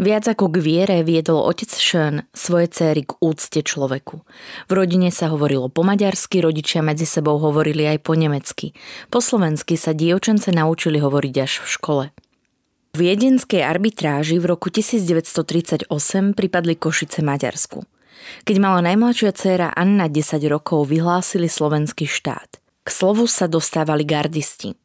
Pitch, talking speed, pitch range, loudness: 165 Hz, 140 wpm, 155-190 Hz, -18 LUFS